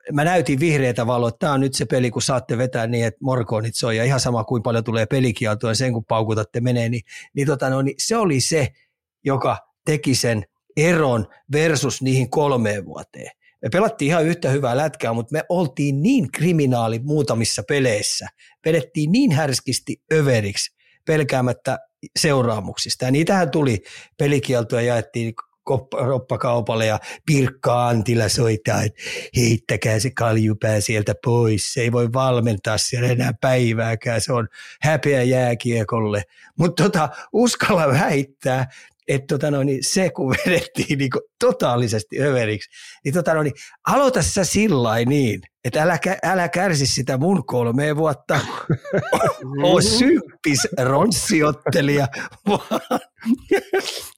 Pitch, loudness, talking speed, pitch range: 130 Hz, -20 LUFS, 135 wpm, 120-155 Hz